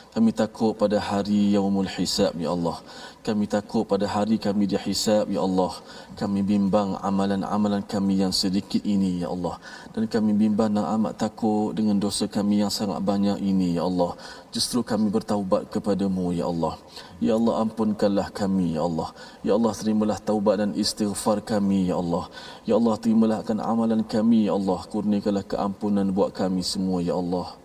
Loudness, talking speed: -24 LUFS, 165 wpm